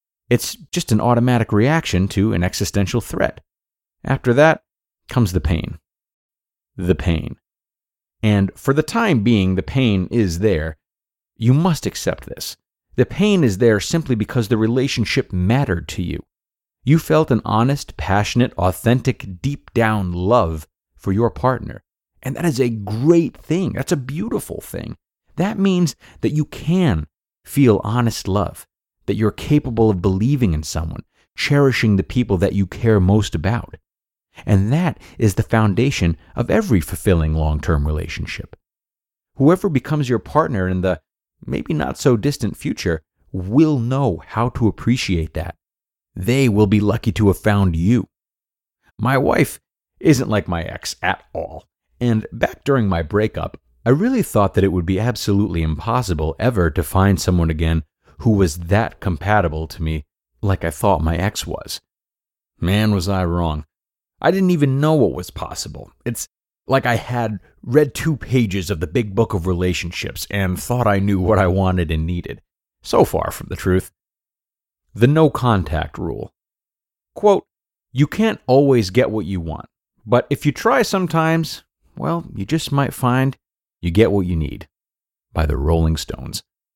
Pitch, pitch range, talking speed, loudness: 105 Hz, 90-130 Hz, 160 wpm, -19 LUFS